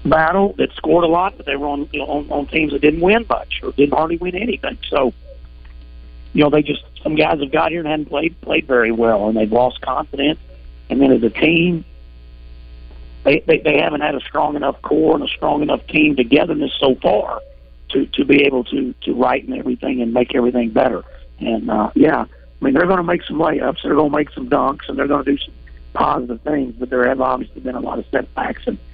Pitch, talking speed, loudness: 135 Hz, 235 wpm, -17 LUFS